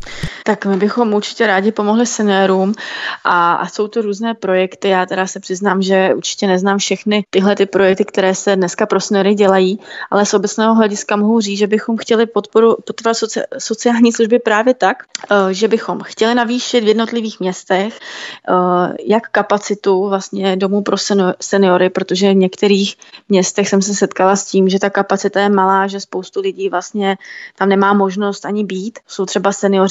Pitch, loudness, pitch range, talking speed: 200 Hz, -14 LUFS, 190-215 Hz, 170 wpm